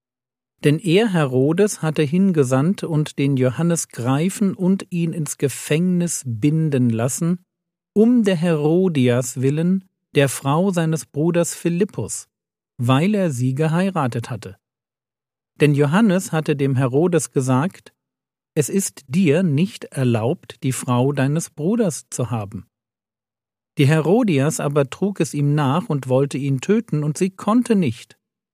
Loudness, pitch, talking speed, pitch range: -19 LUFS, 150 Hz, 130 wpm, 130-180 Hz